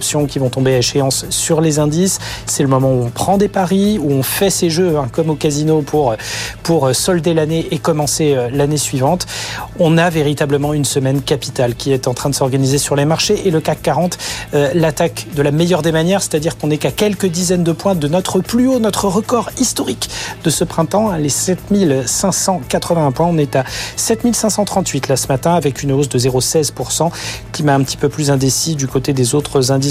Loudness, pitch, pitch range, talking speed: -15 LUFS, 150 Hz, 135-175 Hz, 210 wpm